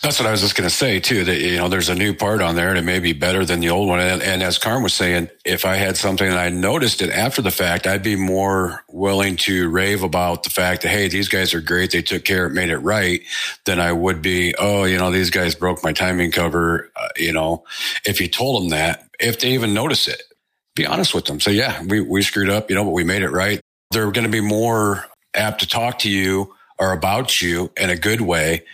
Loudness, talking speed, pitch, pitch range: -18 LUFS, 265 wpm, 95 Hz, 90-100 Hz